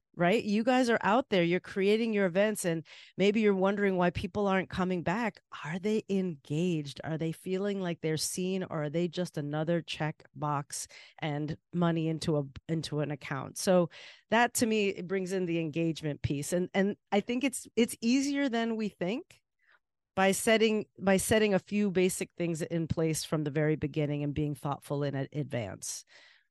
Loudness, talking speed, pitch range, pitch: -31 LUFS, 185 wpm, 155-205 Hz, 180 Hz